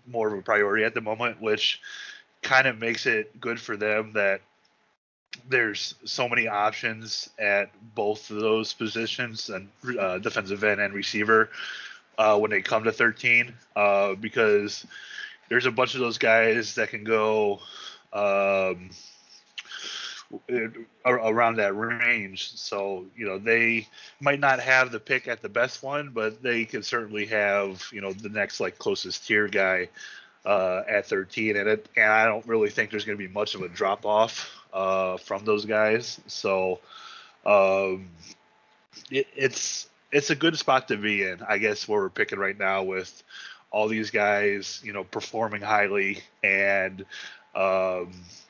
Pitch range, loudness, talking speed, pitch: 100-115 Hz, -25 LUFS, 160 wpm, 110 Hz